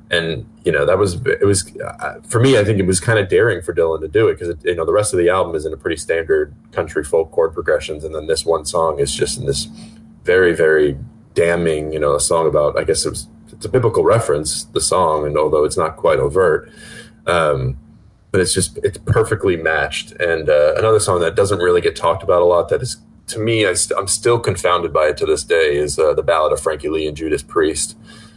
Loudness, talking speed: -17 LUFS, 240 wpm